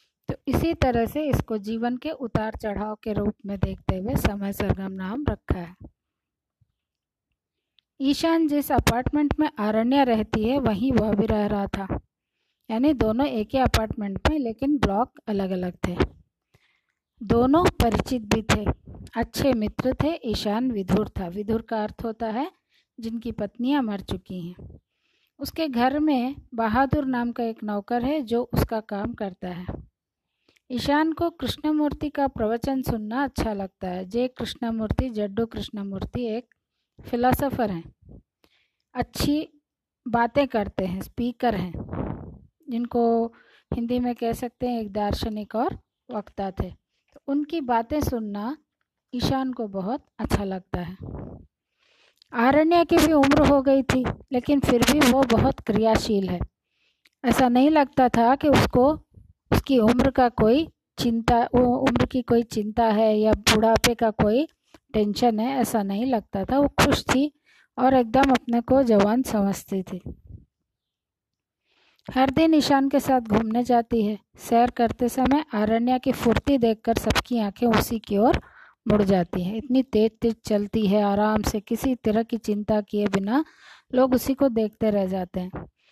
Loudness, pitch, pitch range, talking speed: -24 LUFS, 235 Hz, 215-265 Hz, 150 wpm